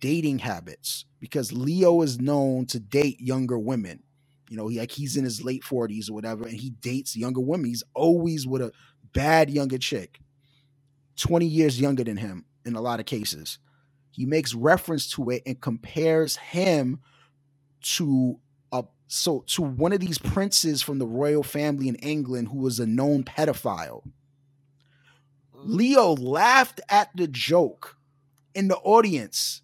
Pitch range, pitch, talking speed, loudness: 125-150 Hz, 140 Hz, 160 wpm, -25 LUFS